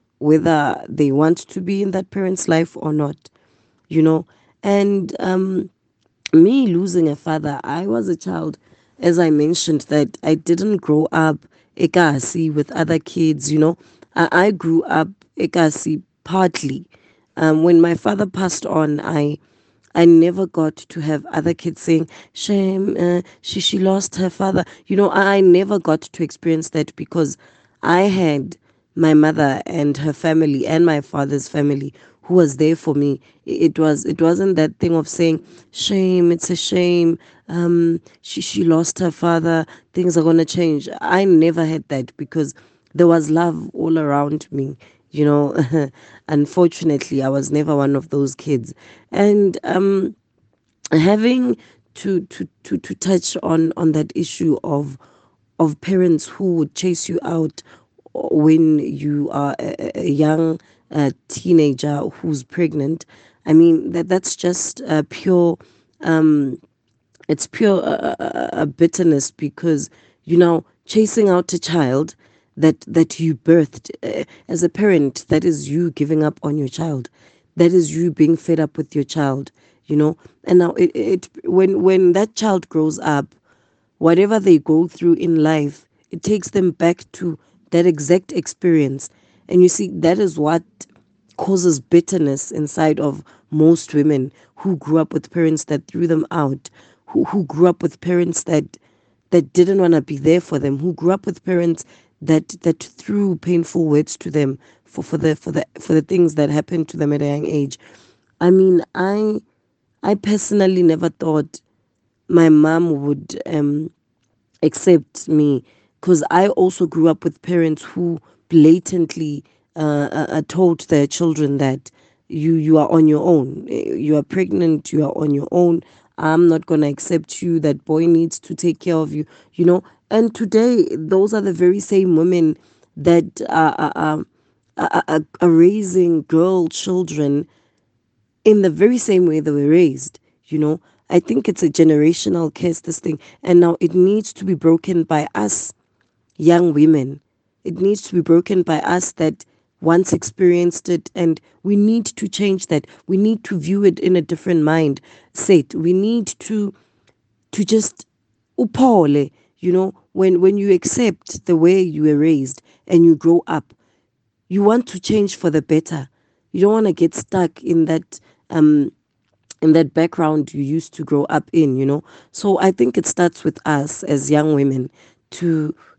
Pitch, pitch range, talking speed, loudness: 165 Hz, 150-180 Hz, 165 wpm, -17 LUFS